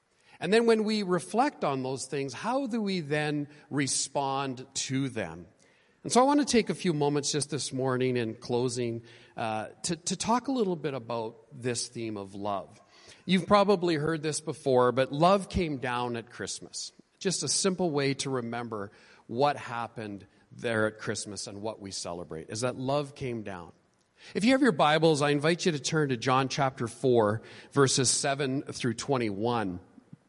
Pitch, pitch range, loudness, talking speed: 135 Hz, 115-160 Hz, -29 LUFS, 180 wpm